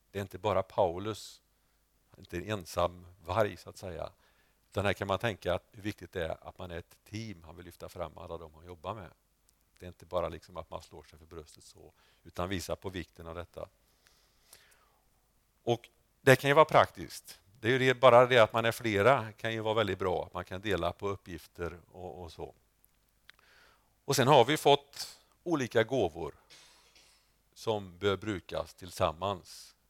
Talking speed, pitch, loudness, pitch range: 190 wpm, 100 Hz, -30 LUFS, 85-110 Hz